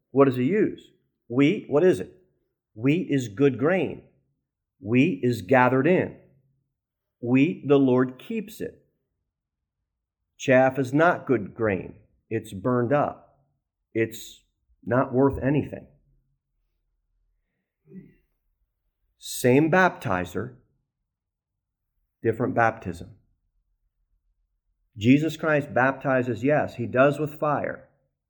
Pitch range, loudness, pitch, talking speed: 95-135 Hz, -23 LUFS, 125 Hz, 95 wpm